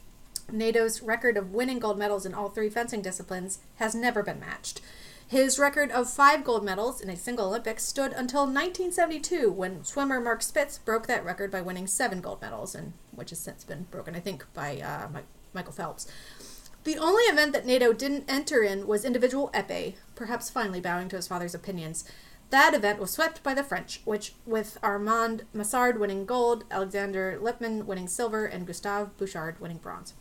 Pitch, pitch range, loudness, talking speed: 225 Hz, 195-255 Hz, -28 LUFS, 185 wpm